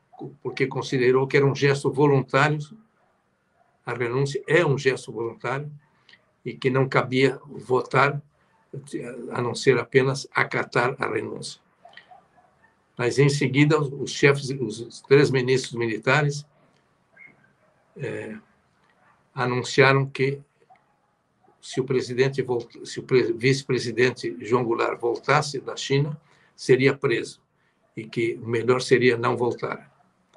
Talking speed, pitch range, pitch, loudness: 110 wpm, 125-140 Hz, 135 Hz, -23 LUFS